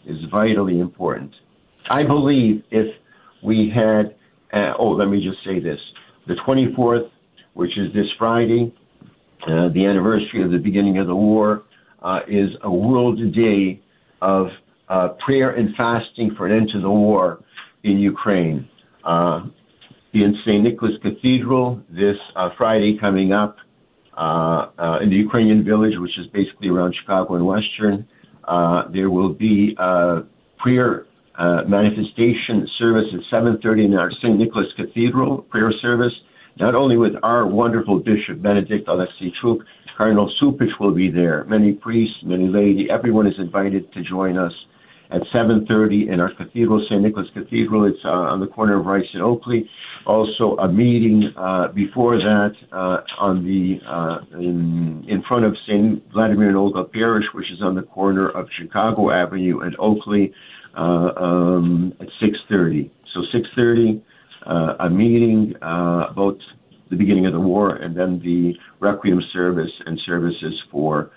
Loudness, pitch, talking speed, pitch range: -19 LUFS, 100 Hz, 155 wpm, 90-110 Hz